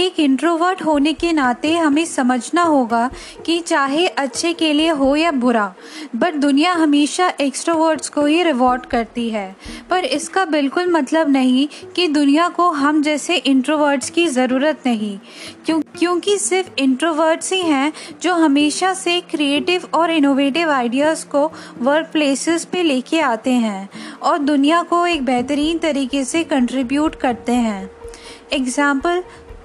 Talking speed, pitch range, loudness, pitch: 140 wpm, 270-335 Hz, -17 LUFS, 300 Hz